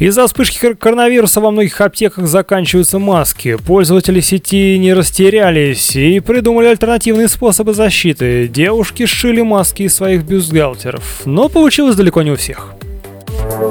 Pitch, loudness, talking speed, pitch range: 190 Hz, -10 LUFS, 125 wpm, 155-220 Hz